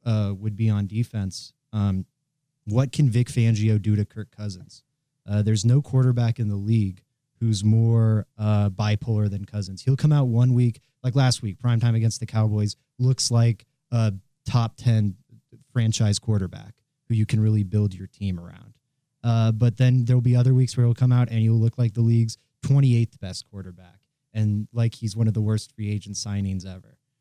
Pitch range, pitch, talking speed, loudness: 105-125 Hz, 115 Hz, 185 wpm, -23 LUFS